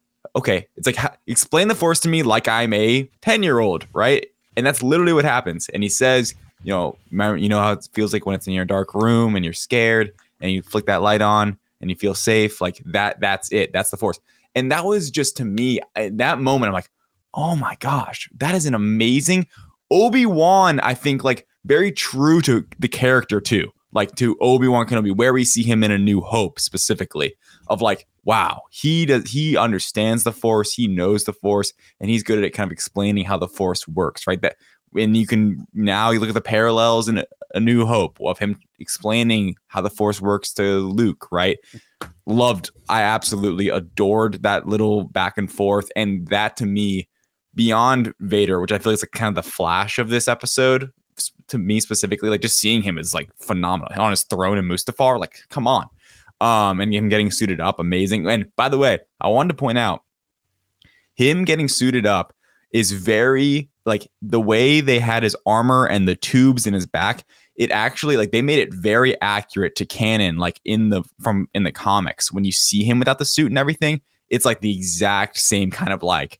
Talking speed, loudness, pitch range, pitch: 205 wpm, -19 LUFS, 100-130 Hz, 110 Hz